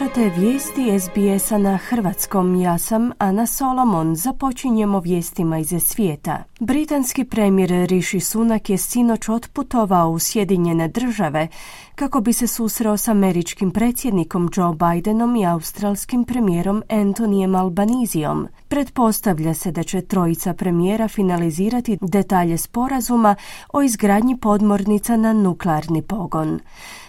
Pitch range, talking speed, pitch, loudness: 180-230 Hz, 115 wpm, 205 Hz, -19 LUFS